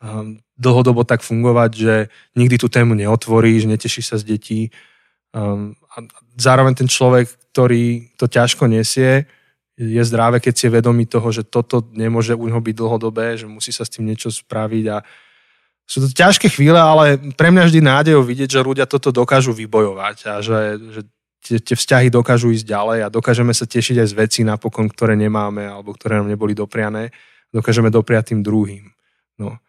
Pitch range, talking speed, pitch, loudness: 110-125 Hz, 170 wpm, 115 Hz, -15 LUFS